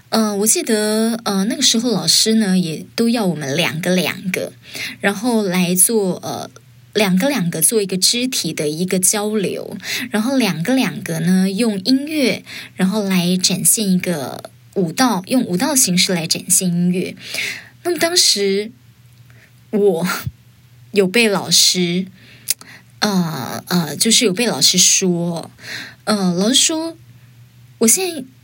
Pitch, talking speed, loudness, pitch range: 190 Hz, 200 characters per minute, -16 LUFS, 170-220 Hz